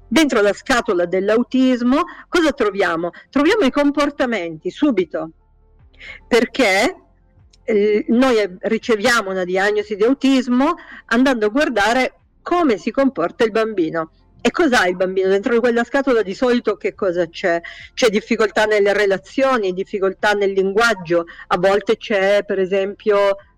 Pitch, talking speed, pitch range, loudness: 215 Hz, 125 wpm, 190-255 Hz, -17 LUFS